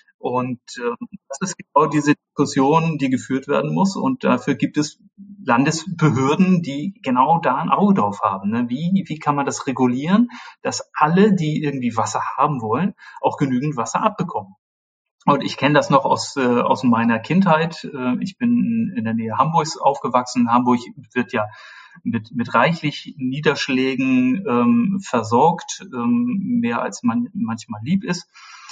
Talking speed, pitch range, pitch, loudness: 155 wpm, 125-205 Hz, 155 Hz, -19 LUFS